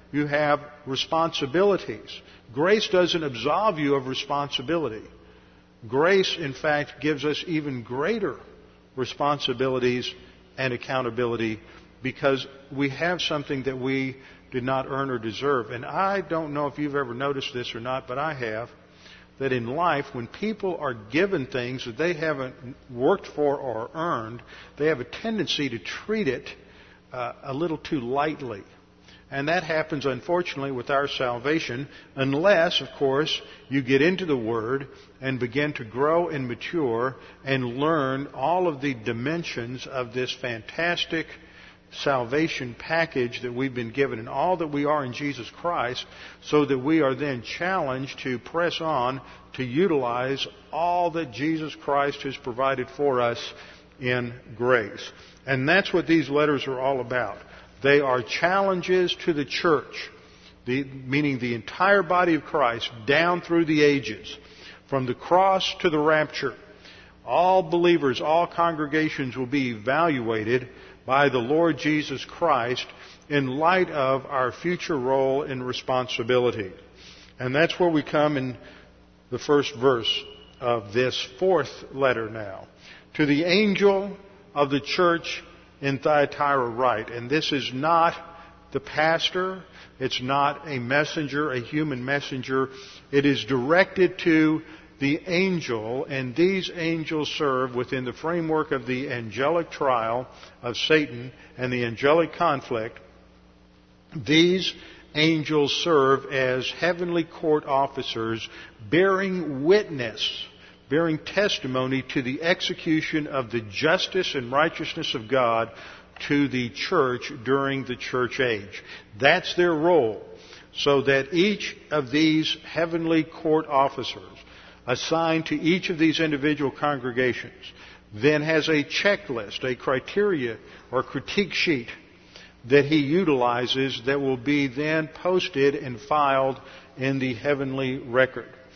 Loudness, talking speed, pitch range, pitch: -24 LUFS, 135 wpm, 130-160 Hz, 140 Hz